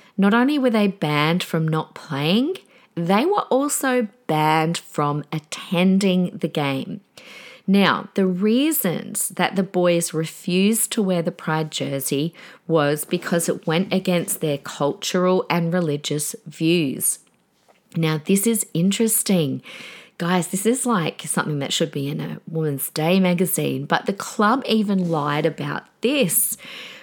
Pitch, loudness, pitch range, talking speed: 180 Hz, -21 LUFS, 160-210 Hz, 140 wpm